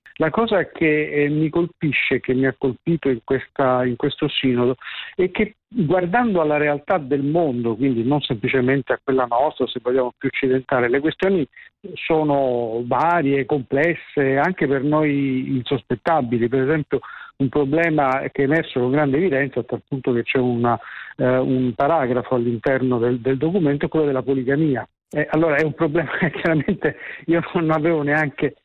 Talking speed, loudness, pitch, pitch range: 165 wpm, -20 LUFS, 140 Hz, 130-155 Hz